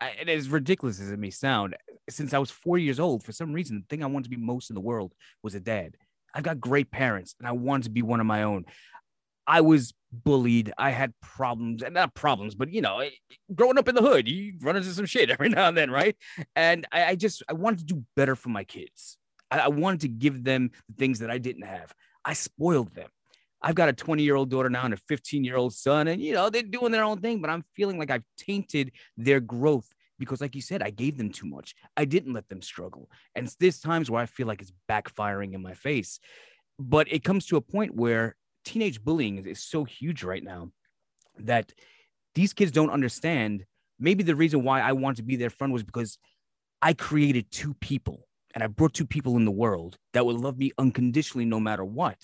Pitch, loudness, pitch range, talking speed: 135 Hz, -27 LUFS, 115-160 Hz, 230 wpm